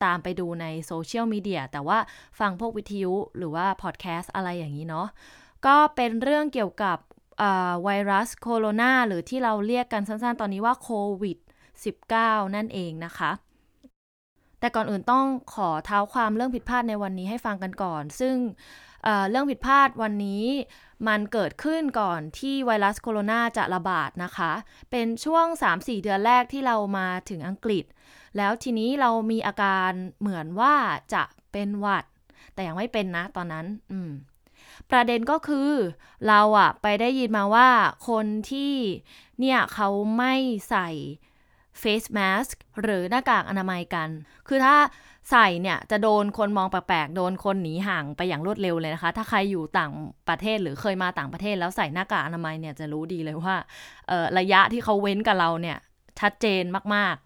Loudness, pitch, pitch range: -25 LUFS, 205 Hz, 180-230 Hz